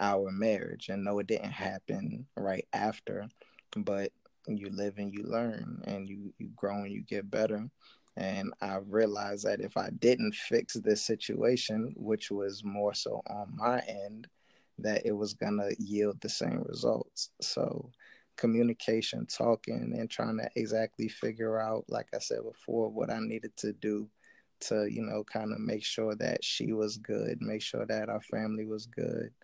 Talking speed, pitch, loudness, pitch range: 170 wpm, 105 Hz, -34 LUFS, 100-110 Hz